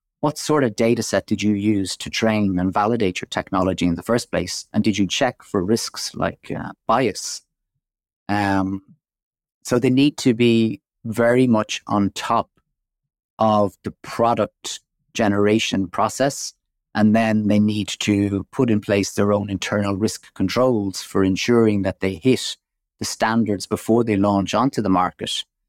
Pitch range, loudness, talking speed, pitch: 100-115 Hz, -20 LUFS, 160 wpm, 105 Hz